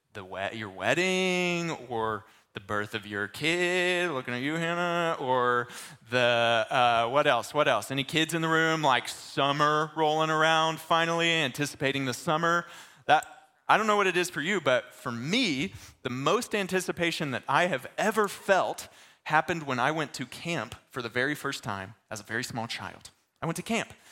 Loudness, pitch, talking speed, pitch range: -27 LUFS, 150 Hz, 180 wpm, 120-170 Hz